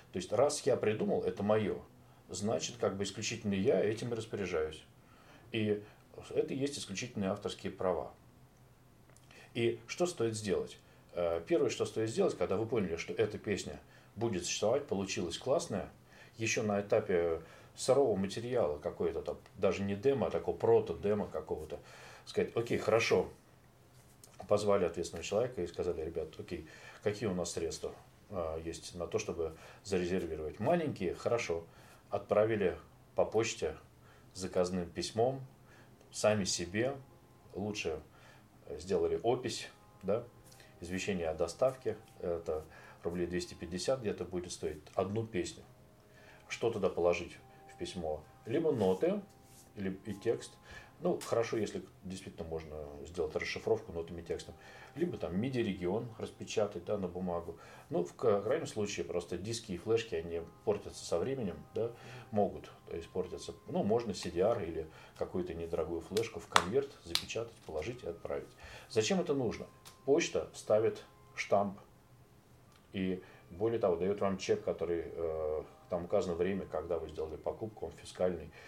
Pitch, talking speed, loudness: 110 Hz, 135 wpm, -36 LUFS